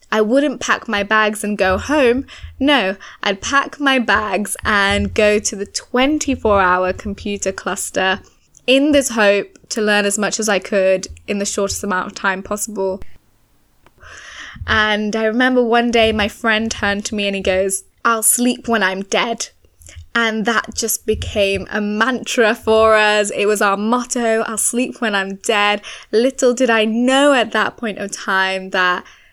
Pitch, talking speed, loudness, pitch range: 215 Hz, 170 wpm, -16 LUFS, 200-235 Hz